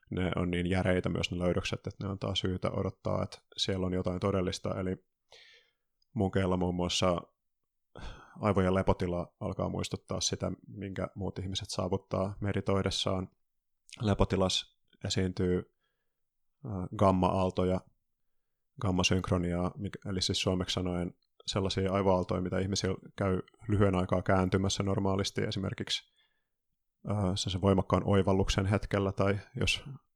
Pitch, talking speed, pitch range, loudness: 95 Hz, 110 wpm, 90-100 Hz, -32 LUFS